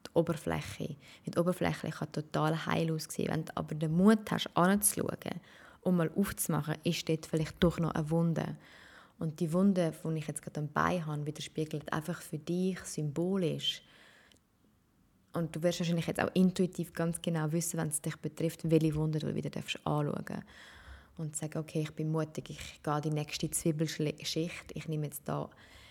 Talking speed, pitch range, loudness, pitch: 165 wpm, 155-175 Hz, -33 LUFS, 160 Hz